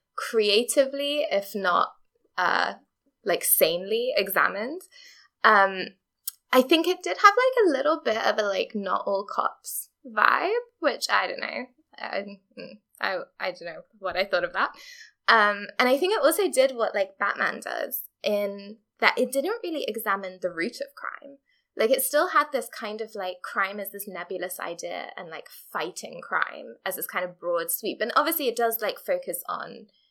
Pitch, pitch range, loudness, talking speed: 255 Hz, 200-325 Hz, -25 LUFS, 175 wpm